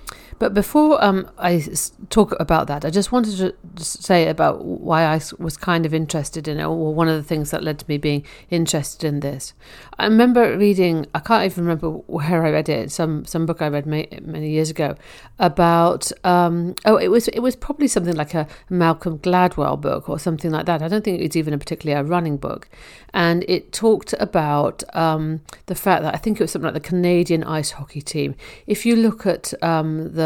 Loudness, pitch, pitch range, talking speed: -20 LUFS, 165 Hz, 155-185 Hz, 210 wpm